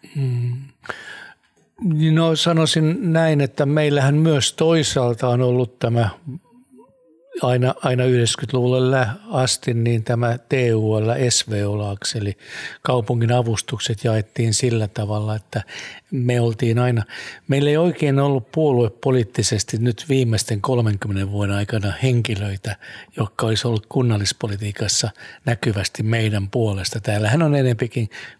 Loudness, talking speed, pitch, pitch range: -20 LUFS, 110 wpm, 120 Hz, 110-135 Hz